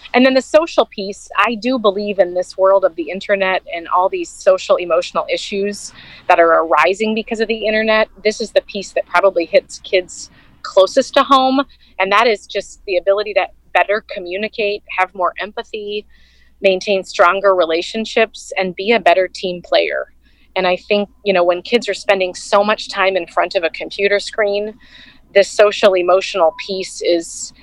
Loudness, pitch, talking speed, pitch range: -16 LUFS, 200 Hz, 180 wpm, 185-225 Hz